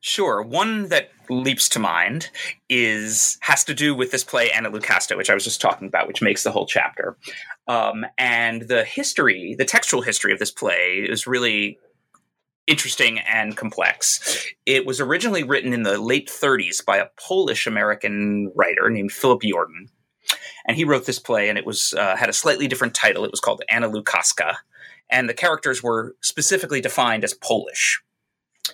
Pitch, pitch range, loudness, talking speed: 125 Hz, 115-150 Hz, -20 LUFS, 175 wpm